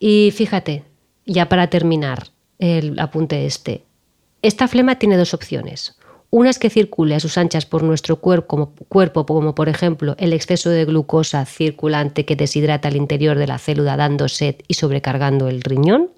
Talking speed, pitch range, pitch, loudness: 165 wpm, 145-180 Hz, 155 Hz, -17 LUFS